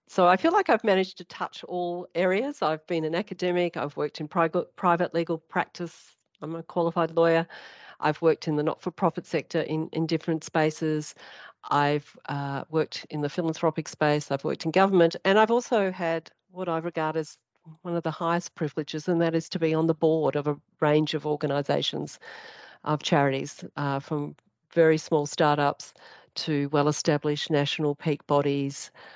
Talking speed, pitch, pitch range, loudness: 175 wpm, 160 Hz, 150-175 Hz, -26 LUFS